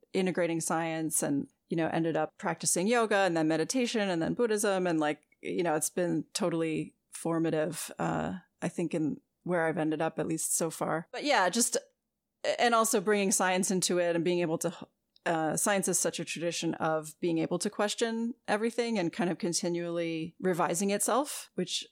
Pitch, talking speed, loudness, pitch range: 175 Hz, 185 wpm, -30 LUFS, 160-210 Hz